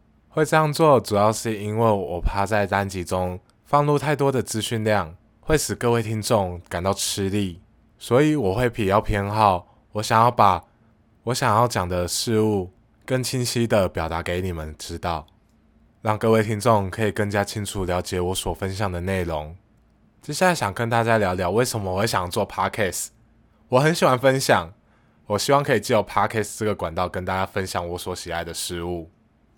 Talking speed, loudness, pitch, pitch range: 290 characters per minute, -22 LUFS, 105 Hz, 90-115 Hz